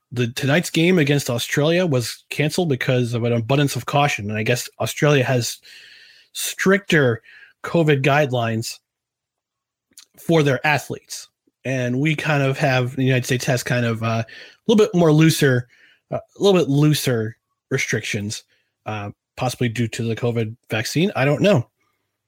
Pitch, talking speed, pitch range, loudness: 130 Hz, 155 wpm, 120-150 Hz, -19 LUFS